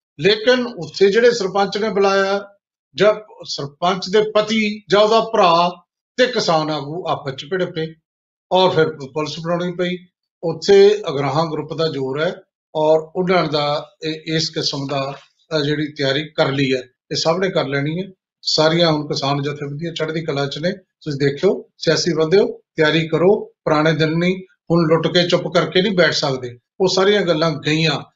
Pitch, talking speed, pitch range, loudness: 165 Hz, 165 wpm, 155-190 Hz, -18 LUFS